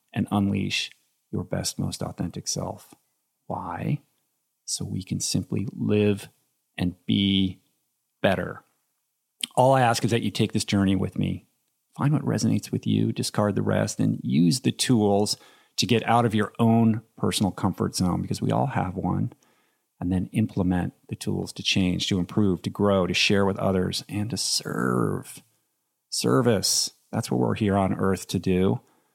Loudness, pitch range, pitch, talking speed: -25 LUFS, 95-110 Hz, 100 Hz, 165 wpm